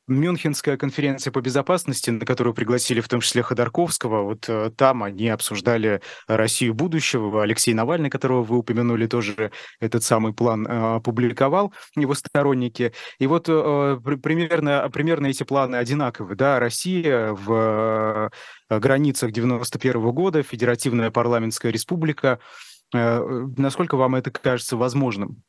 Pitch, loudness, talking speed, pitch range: 125 Hz, -22 LUFS, 120 wpm, 115-140 Hz